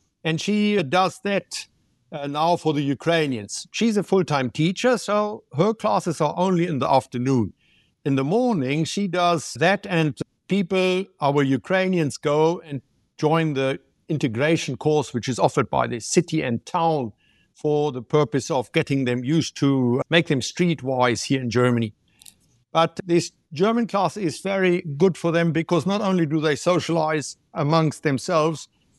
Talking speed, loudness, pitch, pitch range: 155 wpm, -22 LUFS, 160 Hz, 140-180 Hz